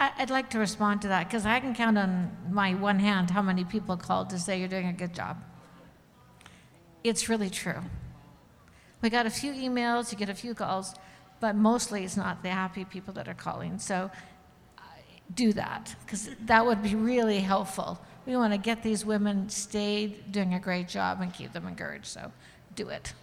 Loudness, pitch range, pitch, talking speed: -29 LUFS, 185-225 Hz, 205 Hz, 195 wpm